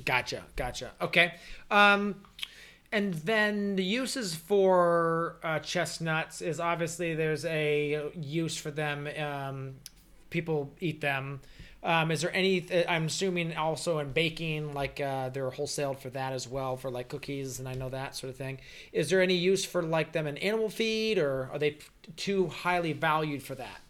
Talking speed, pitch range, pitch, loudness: 170 wpm, 140-175 Hz, 160 Hz, -30 LUFS